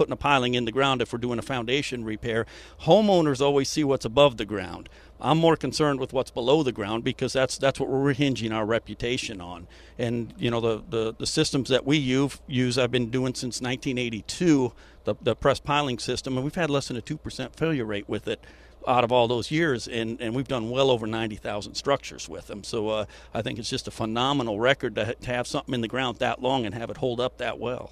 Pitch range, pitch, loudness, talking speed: 115-135 Hz, 125 Hz, -26 LUFS, 230 wpm